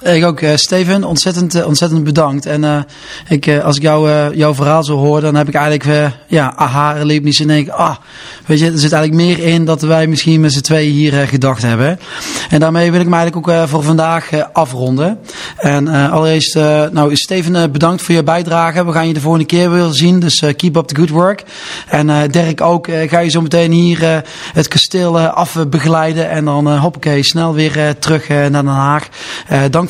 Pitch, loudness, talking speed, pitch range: 160 Hz, -11 LUFS, 230 wpm, 150-170 Hz